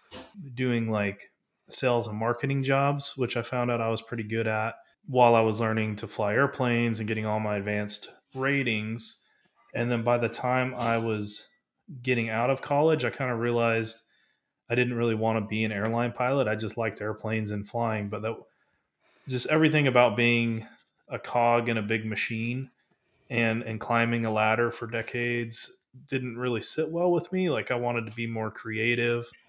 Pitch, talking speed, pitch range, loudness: 115 Hz, 185 wpm, 110-125 Hz, -27 LUFS